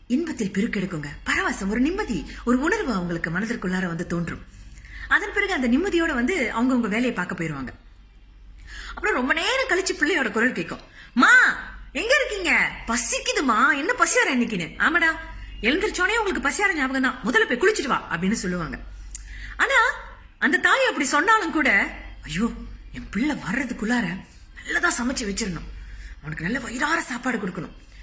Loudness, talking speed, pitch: -22 LUFS, 140 wpm, 245 Hz